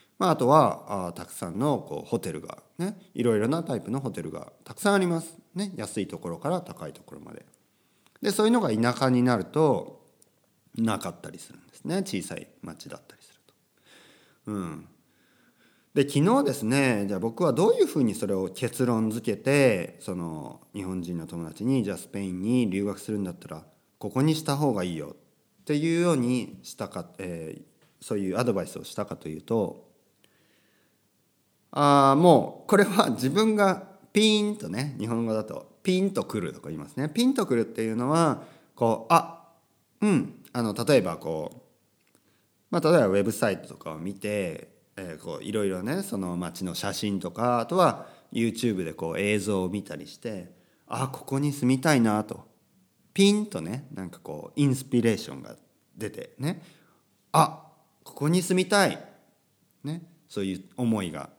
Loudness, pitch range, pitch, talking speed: -26 LUFS, 100-165 Hz, 120 Hz, 330 characters per minute